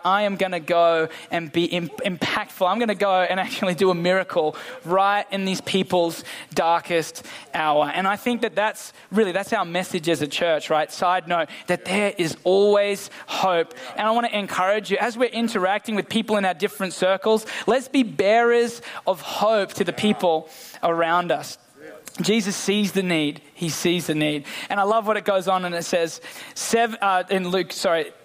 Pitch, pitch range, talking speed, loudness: 190 Hz, 175-210 Hz, 190 wpm, -22 LUFS